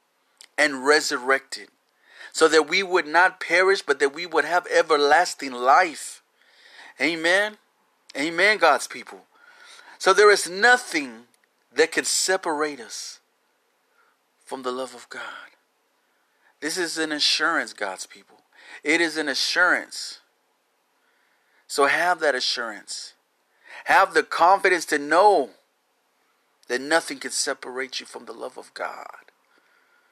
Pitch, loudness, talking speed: 195 Hz, -21 LUFS, 120 wpm